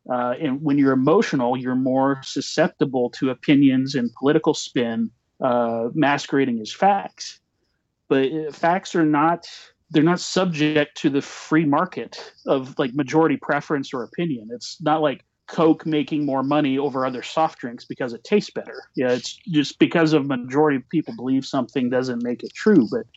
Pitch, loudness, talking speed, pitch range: 145 Hz, -21 LUFS, 165 wpm, 130-160 Hz